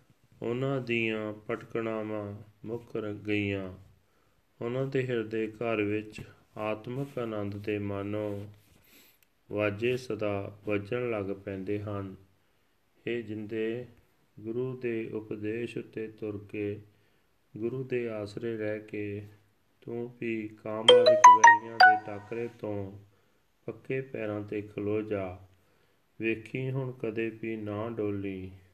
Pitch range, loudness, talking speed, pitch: 105-115 Hz, -29 LUFS, 110 wpm, 110 Hz